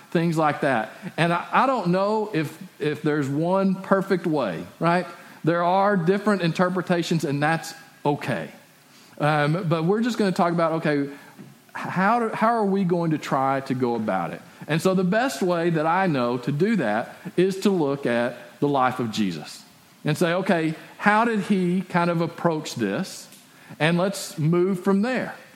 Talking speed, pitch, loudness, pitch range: 180 wpm, 170 Hz, -23 LUFS, 150-190 Hz